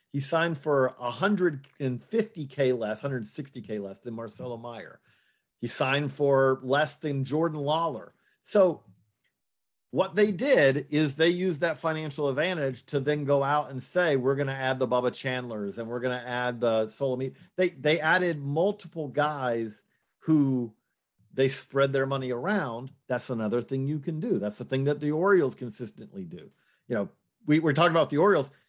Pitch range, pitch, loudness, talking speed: 125-155 Hz, 140 Hz, -27 LUFS, 165 wpm